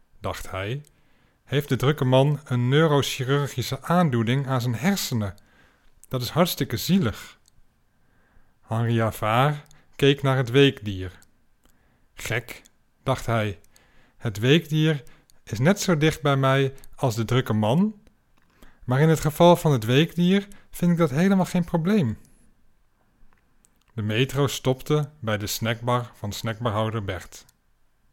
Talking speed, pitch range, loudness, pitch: 125 wpm, 115-155 Hz, -23 LUFS, 135 Hz